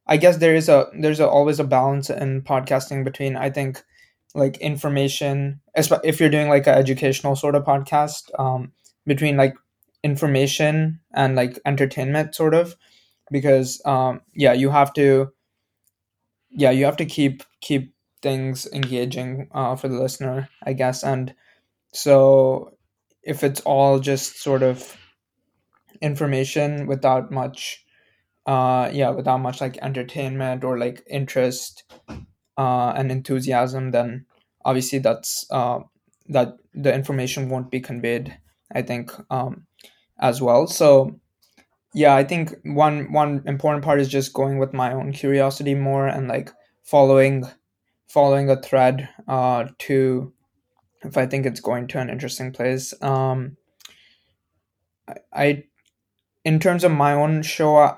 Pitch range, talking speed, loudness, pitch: 130-145 Hz, 140 wpm, -20 LUFS, 135 Hz